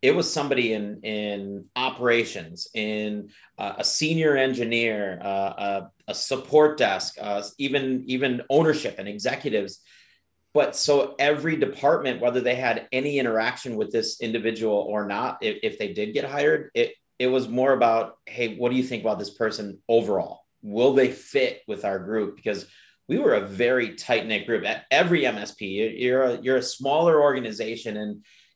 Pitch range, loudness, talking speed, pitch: 105-135 Hz, -24 LUFS, 170 wpm, 120 Hz